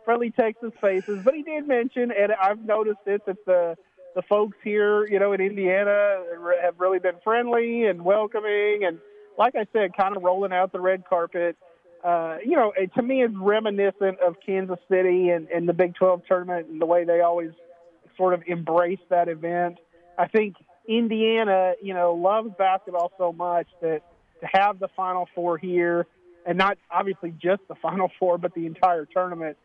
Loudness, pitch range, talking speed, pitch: -24 LUFS, 175-205 Hz, 185 wpm, 185 Hz